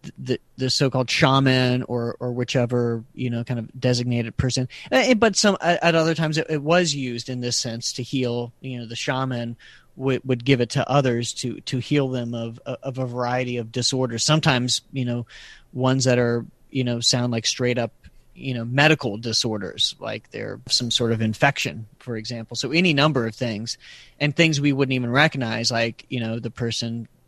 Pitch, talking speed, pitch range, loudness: 125 Hz, 190 wpm, 120-135 Hz, -22 LUFS